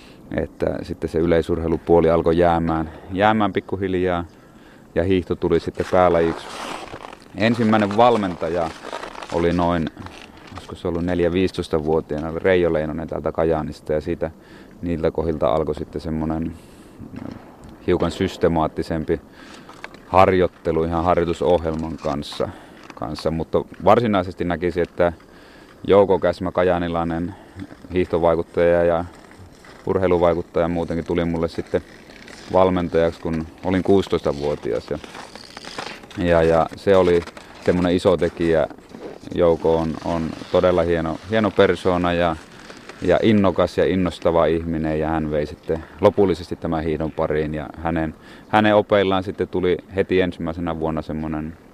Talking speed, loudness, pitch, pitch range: 110 wpm, -21 LUFS, 85 Hz, 80-90 Hz